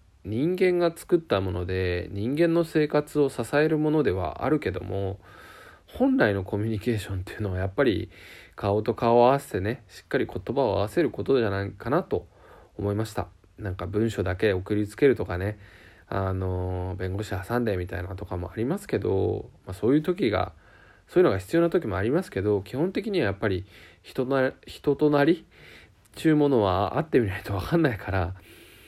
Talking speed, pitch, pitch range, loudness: 380 characters per minute, 105 Hz, 95-145 Hz, -26 LUFS